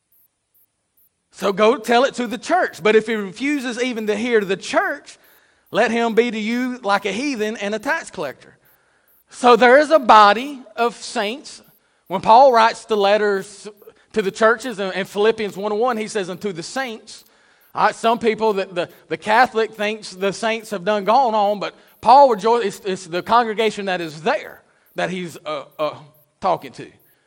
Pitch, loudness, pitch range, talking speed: 215 Hz, -18 LUFS, 195-235 Hz, 180 wpm